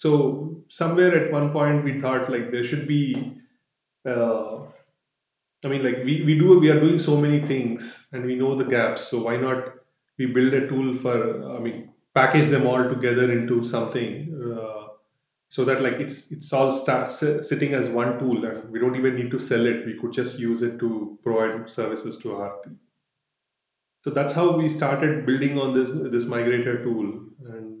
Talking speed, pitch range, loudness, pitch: 190 wpm, 120-145 Hz, -23 LUFS, 130 Hz